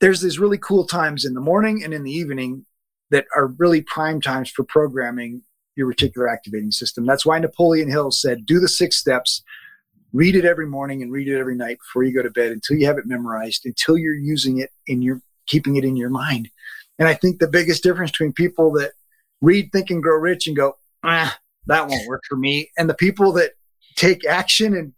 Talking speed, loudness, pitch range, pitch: 220 wpm, -19 LUFS, 130-175 Hz, 155 Hz